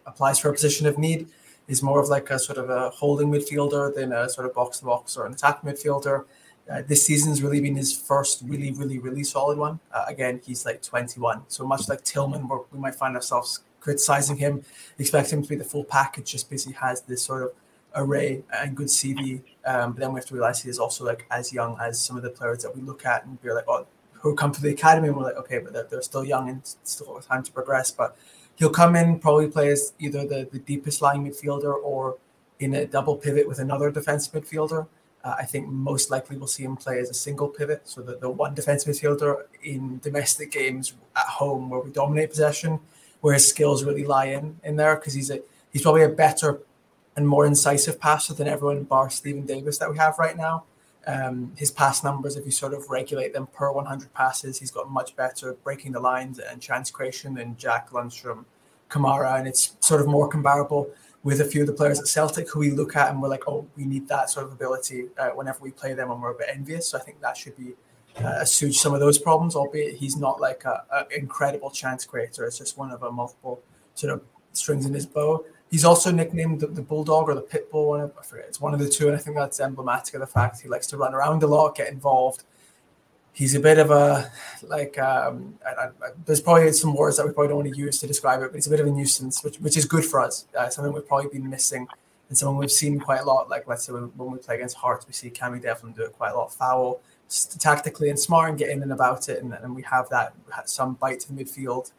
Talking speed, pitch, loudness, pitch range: 240 wpm, 140 Hz, -24 LUFS, 130-150 Hz